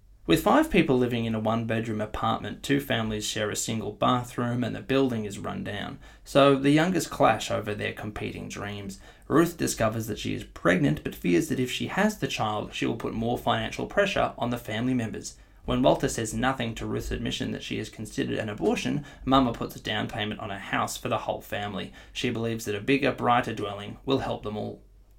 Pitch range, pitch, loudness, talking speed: 105-130 Hz, 115 Hz, -27 LUFS, 210 wpm